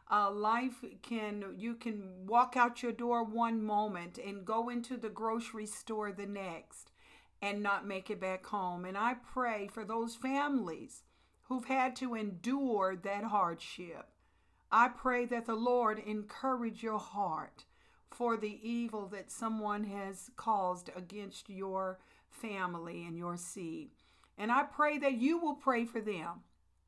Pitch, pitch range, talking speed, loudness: 220 Hz, 200-240 Hz, 150 wpm, -36 LUFS